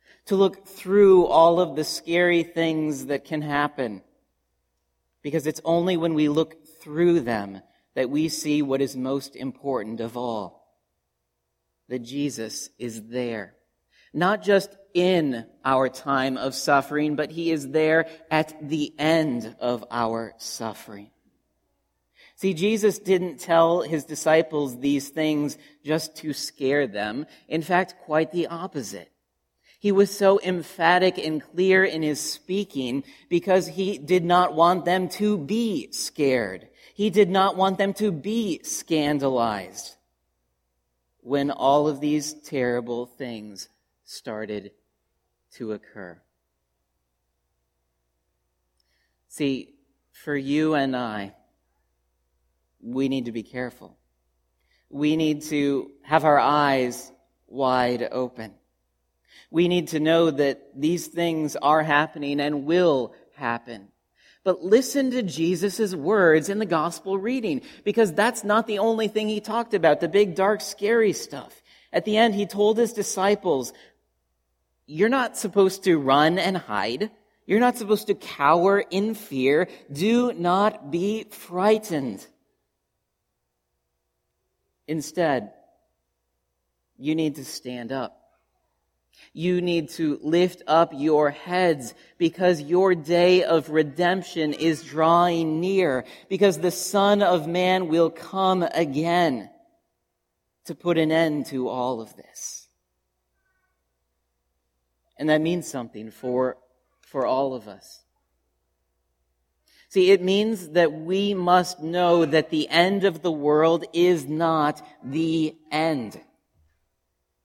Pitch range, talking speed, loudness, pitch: 115-180 Hz, 125 wpm, -23 LUFS, 150 Hz